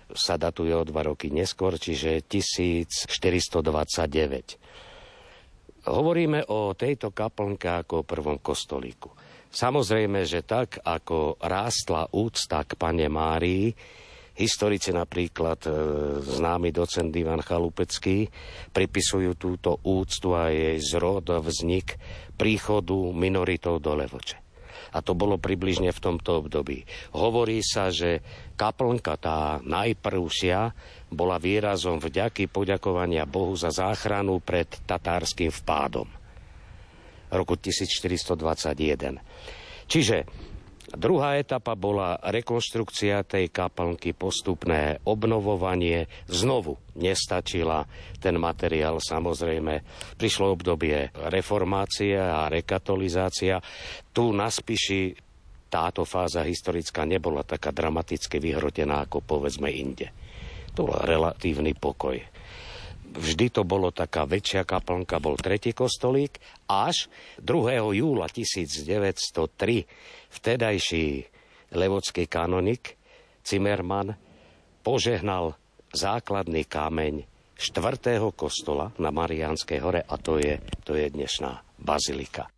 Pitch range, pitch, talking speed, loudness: 80-100 Hz, 90 Hz, 100 wpm, -27 LUFS